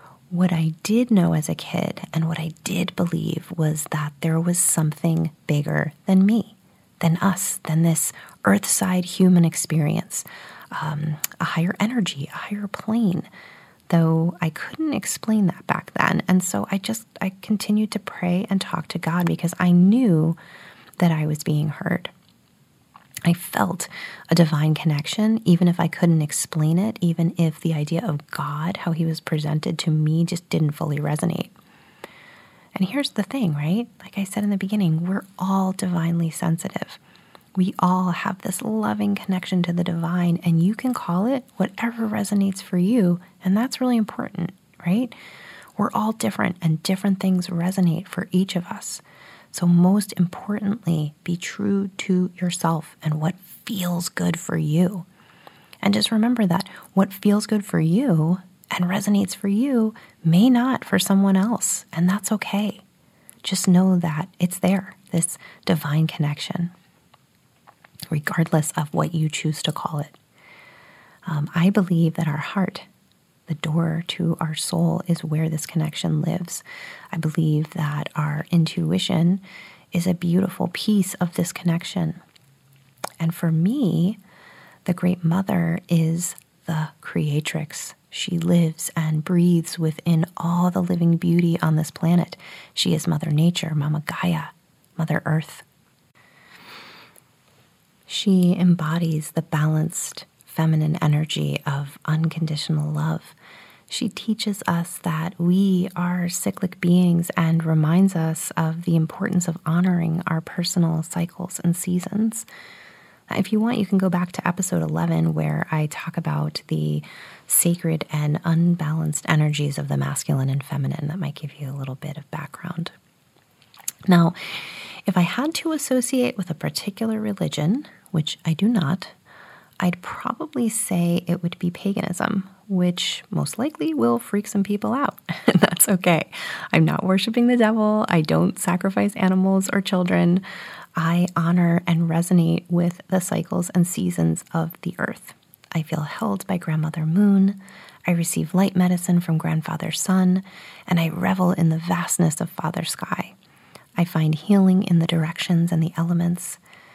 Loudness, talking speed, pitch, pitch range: -22 LUFS, 150 wpm, 175 Hz, 160-190 Hz